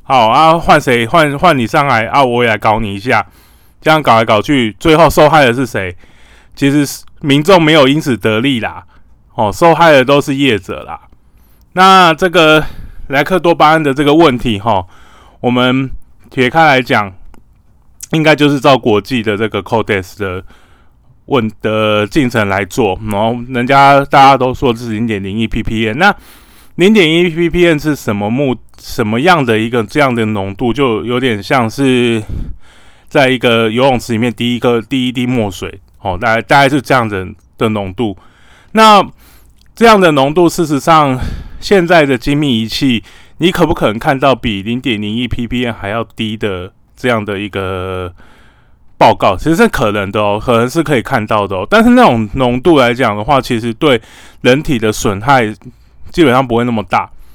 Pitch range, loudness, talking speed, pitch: 110-145 Hz, -11 LUFS, 260 characters per minute, 120 Hz